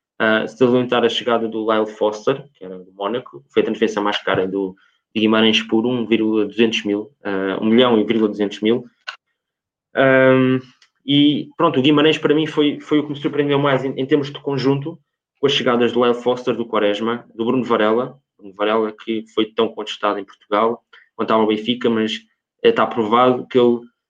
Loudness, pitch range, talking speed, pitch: -18 LUFS, 110-130 Hz, 195 wpm, 115 Hz